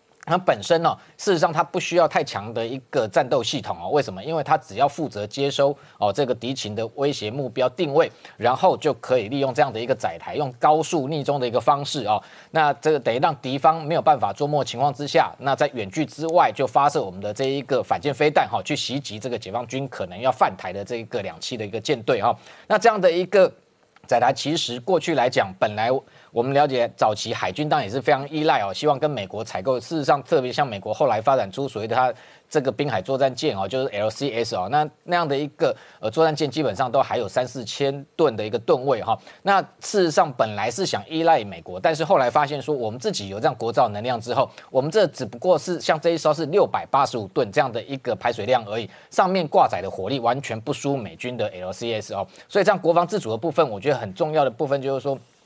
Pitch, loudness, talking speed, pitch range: 140 Hz, -22 LUFS, 360 characters per minute, 125-155 Hz